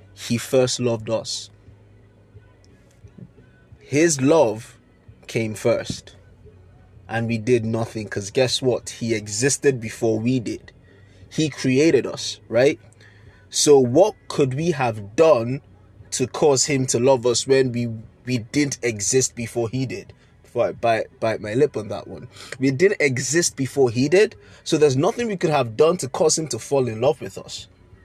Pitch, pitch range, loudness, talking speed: 120 Hz, 105-135 Hz, -21 LUFS, 160 wpm